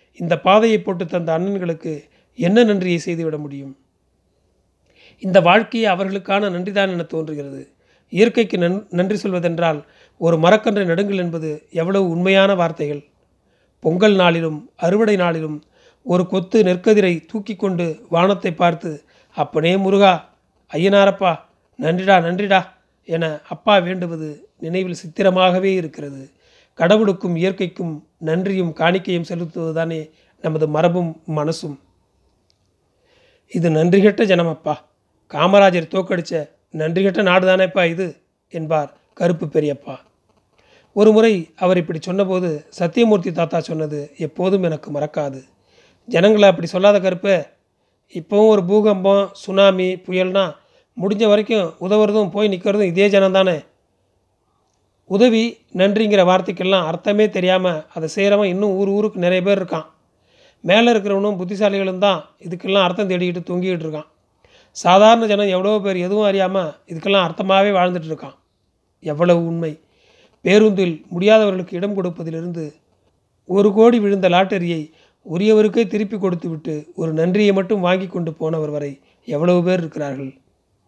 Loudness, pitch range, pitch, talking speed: -17 LUFS, 160-200 Hz, 180 Hz, 110 wpm